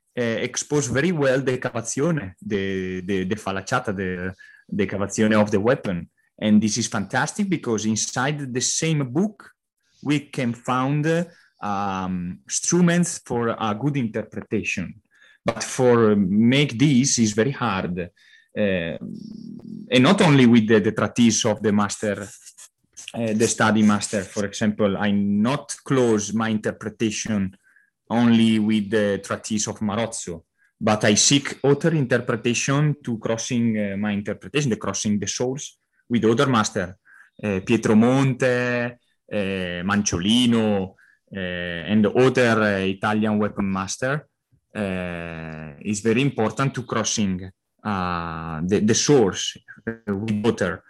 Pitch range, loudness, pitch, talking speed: 100-130 Hz, -22 LUFS, 110 Hz, 130 wpm